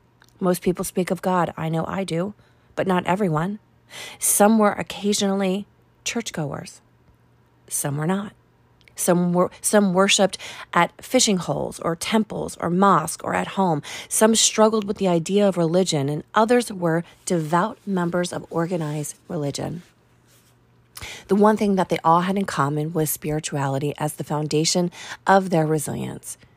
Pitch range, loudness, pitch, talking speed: 160-200 Hz, -22 LUFS, 180 Hz, 145 wpm